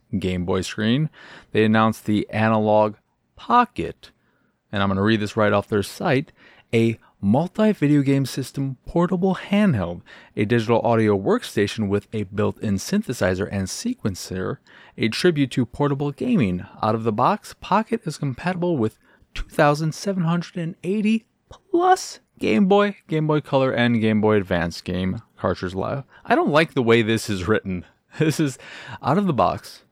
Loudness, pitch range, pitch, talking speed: -22 LUFS, 105-160 Hz, 120 Hz, 150 wpm